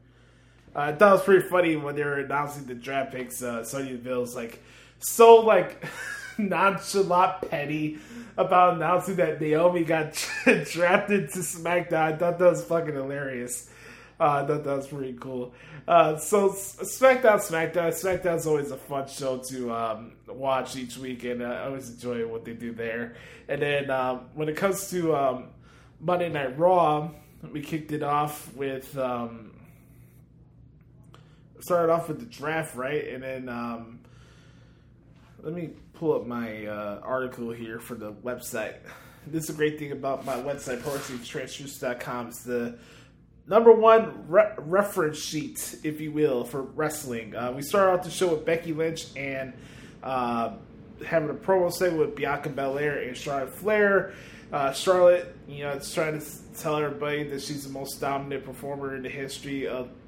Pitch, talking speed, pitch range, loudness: 145 Hz, 165 wpm, 130-165 Hz, -26 LUFS